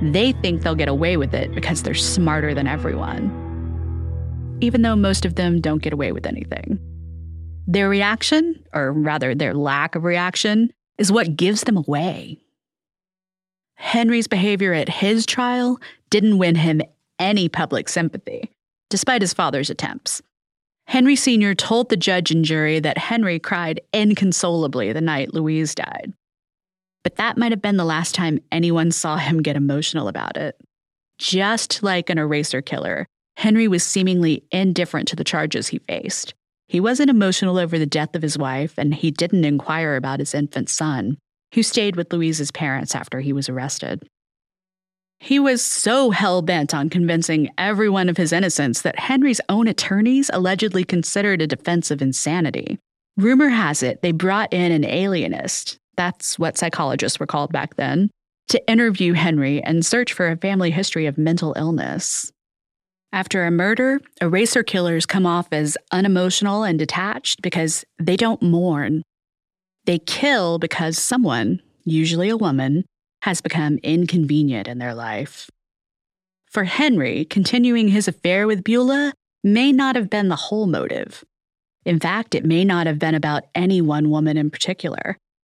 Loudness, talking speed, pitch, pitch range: -19 LUFS, 155 wpm, 175 Hz, 155-205 Hz